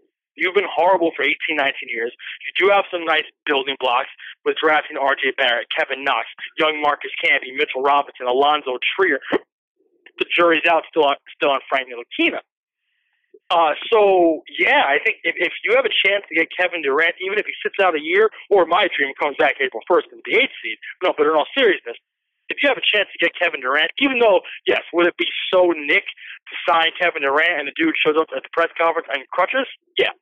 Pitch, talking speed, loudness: 205 Hz, 210 wpm, -18 LUFS